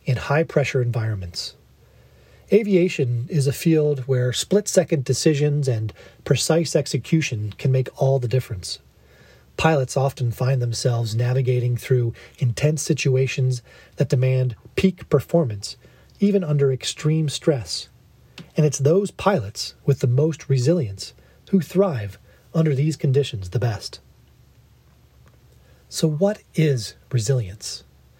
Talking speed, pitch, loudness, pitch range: 115 wpm, 130 Hz, -22 LUFS, 115-155 Hz